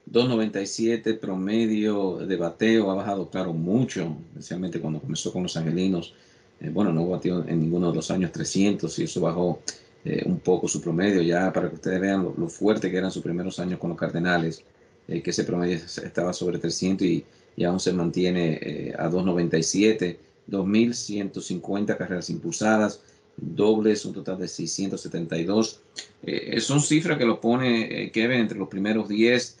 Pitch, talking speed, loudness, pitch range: 95 Hz, 170 wpm, -25 LUFS, 90-110 Hz